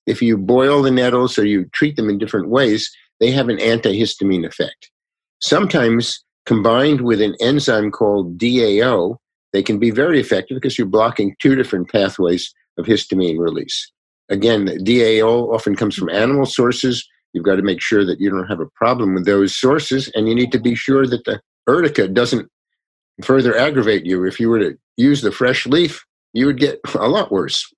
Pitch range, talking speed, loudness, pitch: 105-130 Hz, 190 wpm, -16 LUFS, 115 Hz